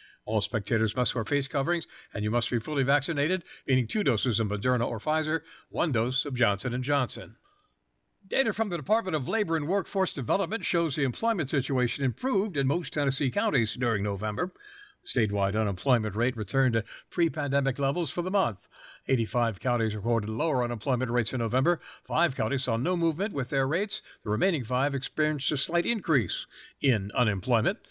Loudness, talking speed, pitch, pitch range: -28 LUFS, 170 wpm, 135 Hz, 115-160 Hz